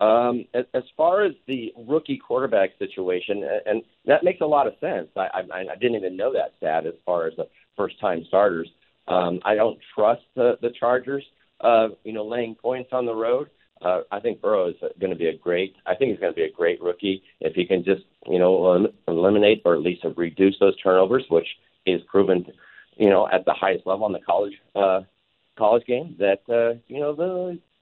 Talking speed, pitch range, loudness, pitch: 210 wpm, 95-165 Hz, -23 LUFS, 120 Hz